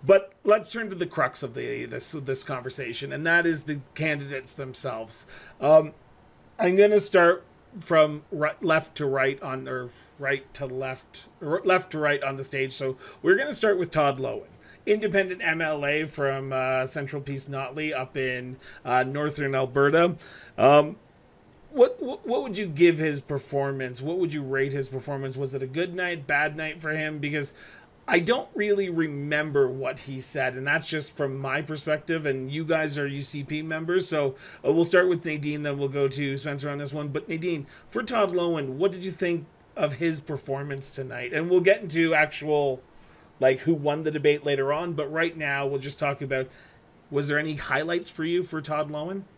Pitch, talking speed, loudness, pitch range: 150 Hz, 190 wpm, -26 LUFS, 135-165 Hz